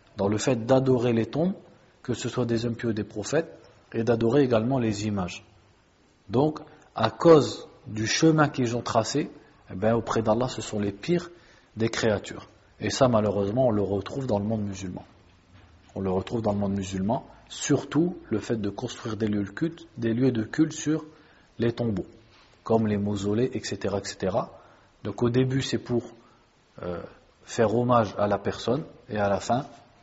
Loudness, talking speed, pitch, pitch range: -26 LUFS, 180 wpm, 115 Hz, 100-130 Hz